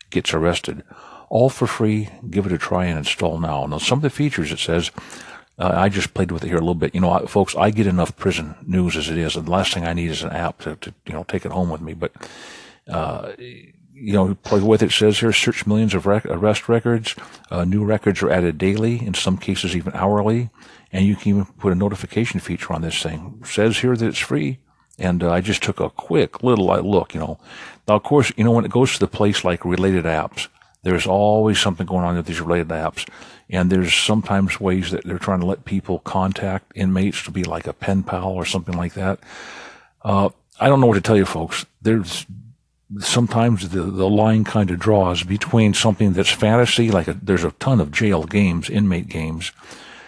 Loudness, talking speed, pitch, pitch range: -19 LUFS, 230 wpm, 95 Hz, 90-110 Hz